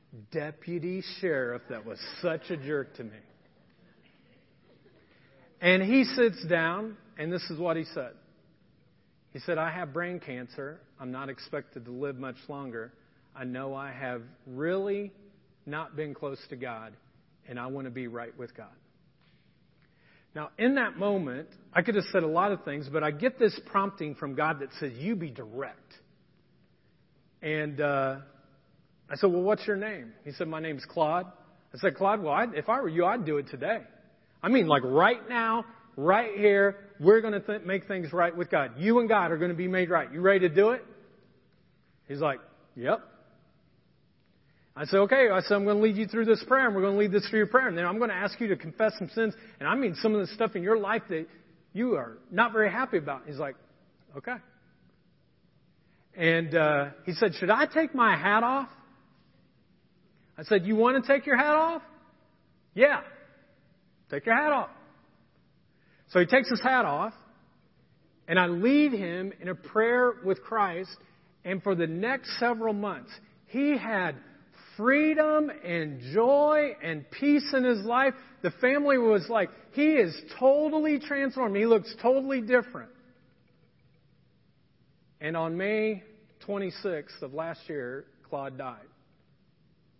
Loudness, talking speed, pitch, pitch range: -27 LUFS, 175 wpm, 185 Hz, 155-225 Hz